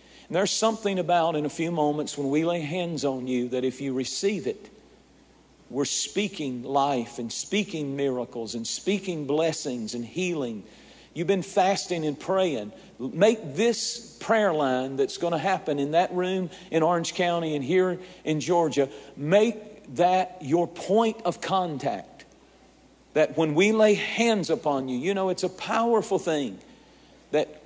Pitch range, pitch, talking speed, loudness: 145-190 Hz, 170 Hz, 160 wpm, -26 LUFS